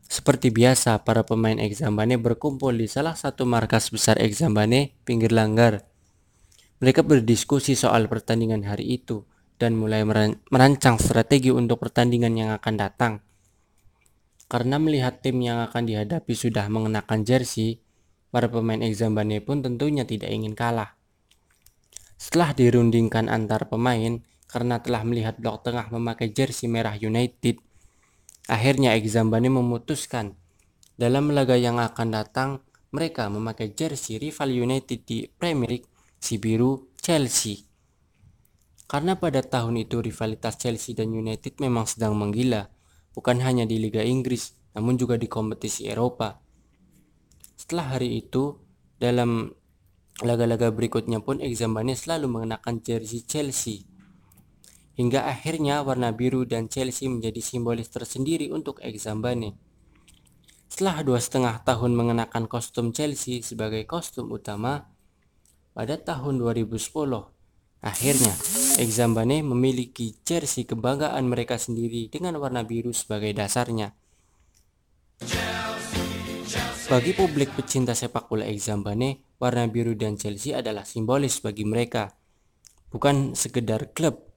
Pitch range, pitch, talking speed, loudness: 110-130 Hz, 115 Hz, 115 wpm, -24 LUFS